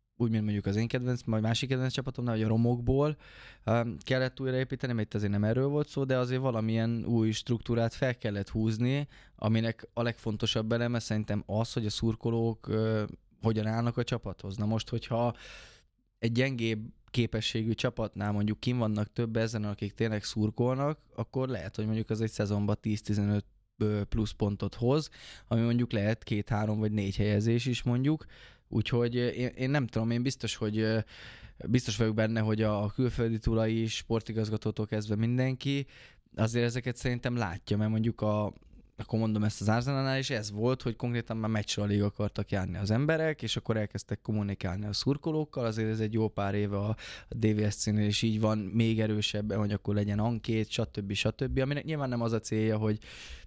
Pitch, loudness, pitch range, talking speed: 110 Hz, -31 LUFS, 105-120 Hz, 170 wpm